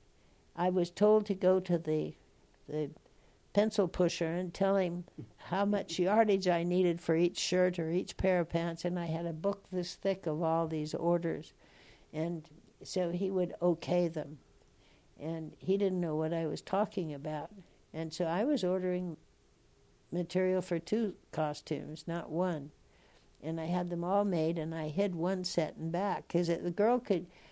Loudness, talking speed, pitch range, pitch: -33 LUFS, 175 wpm, 160-185 Hz, 175 Hz